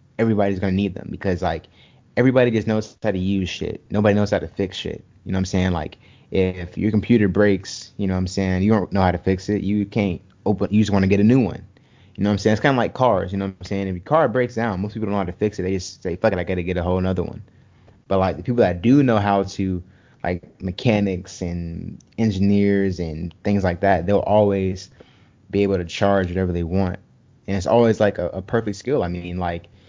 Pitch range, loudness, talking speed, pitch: 95-105 Hz, -21 LUFS, 260 wpm, 100 Hz